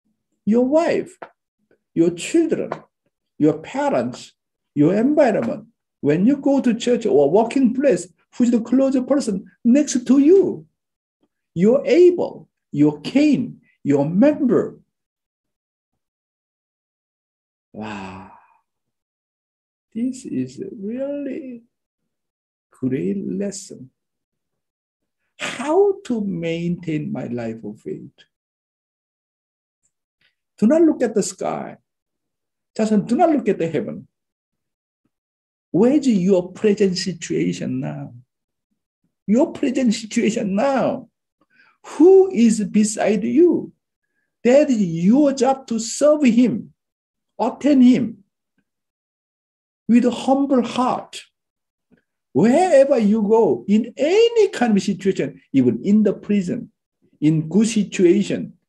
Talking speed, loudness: 100 wpm, -18 LUFS